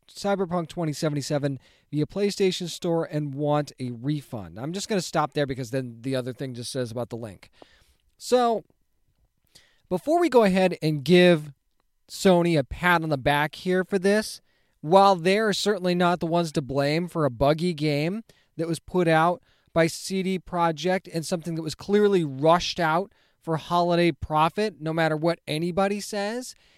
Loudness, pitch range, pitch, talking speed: -24 LUFS, 145-185 Hz, 165 Hz, 170 wpm